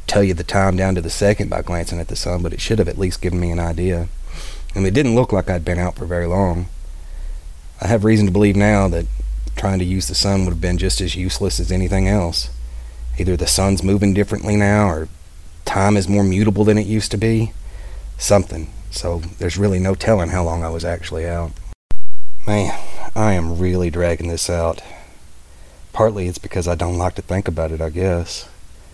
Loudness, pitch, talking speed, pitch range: -19 LUFS, 90 Hz, 215 wpm, 85-100 Hz